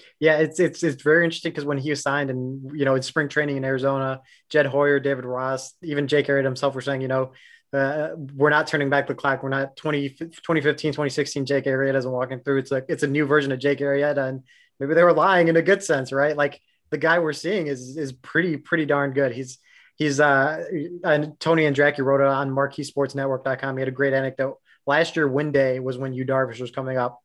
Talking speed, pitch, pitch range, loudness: 235 wpm, 140 Hz, 135-150 Hz, -22 LUFS